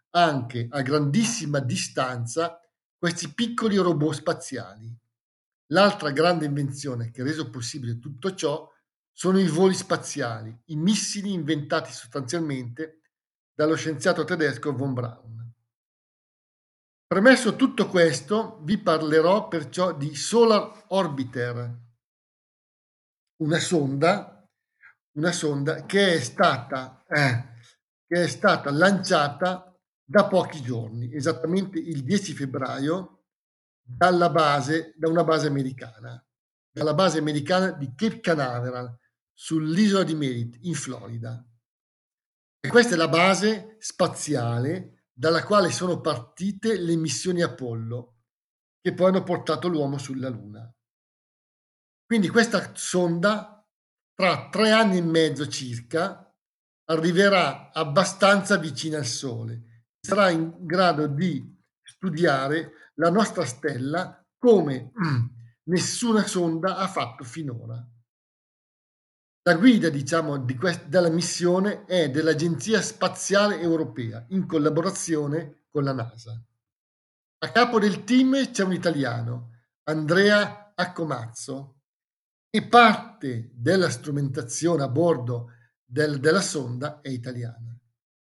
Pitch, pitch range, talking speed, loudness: 160 Hz, 130-180 Hz, 110 wpm, -24 LUFS